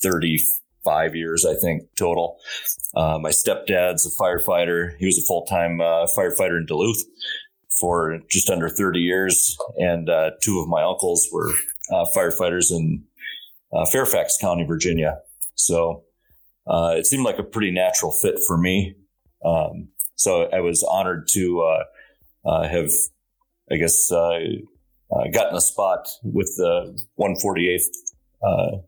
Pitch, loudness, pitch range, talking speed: 85 Hz, -20 LUFS, 85-95 Hz, 140 wpm